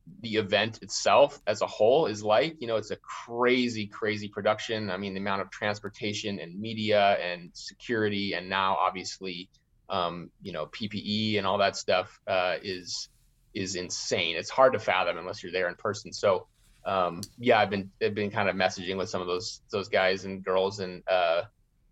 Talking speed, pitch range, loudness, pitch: 190 wpm, 95-110 Hz, -28 LUFS, 100 Hz